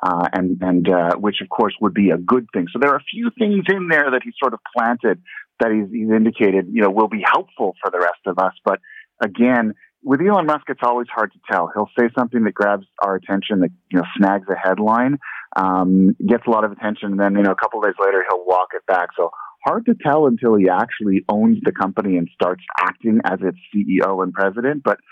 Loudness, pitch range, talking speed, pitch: -18 LUFS, 95-125 Hz, 240 wpm, 110 Hz